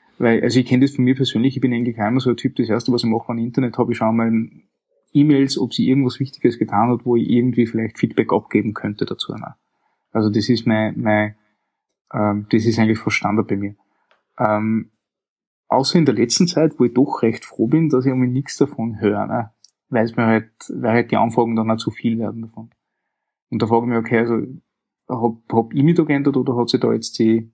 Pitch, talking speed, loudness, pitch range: 115 Hz, 230 wpm, -19 LUFS, 110-130 Hz